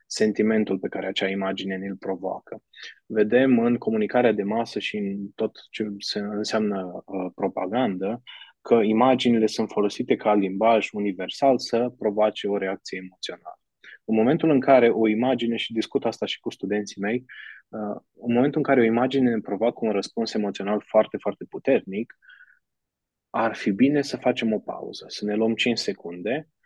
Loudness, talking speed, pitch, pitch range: -24 LUFS, 160 wpm, 110 Hz, 100-120 Hz